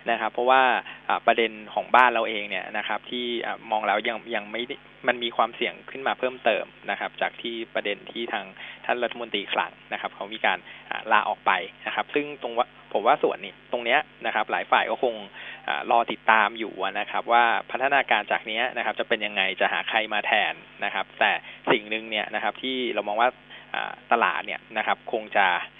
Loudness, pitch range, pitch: -25 LUFS, 105-125 Hz, 115 Hz